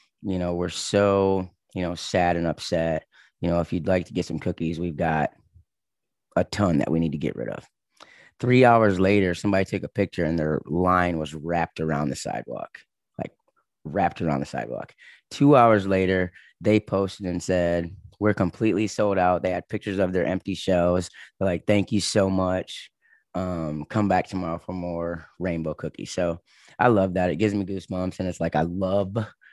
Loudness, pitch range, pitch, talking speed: -24 LUFS, 85-100 Hz, 90 Hz, 190 wpm